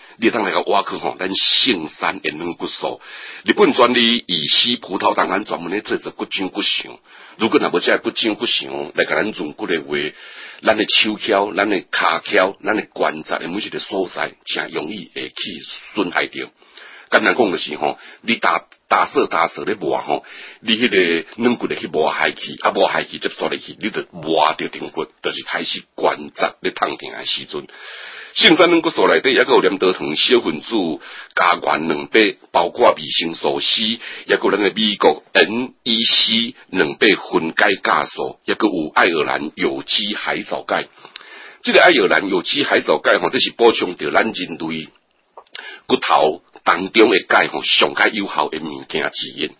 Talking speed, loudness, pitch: 260 characters per minute, -16 LUFS, 115 Hz